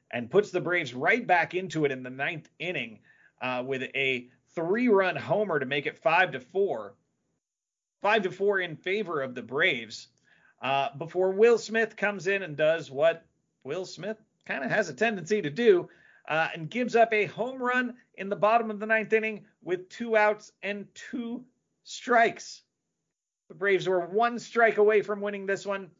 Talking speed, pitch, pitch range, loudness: 185 wpm, 200 Hz, 165-220 Hz, -27 LUFS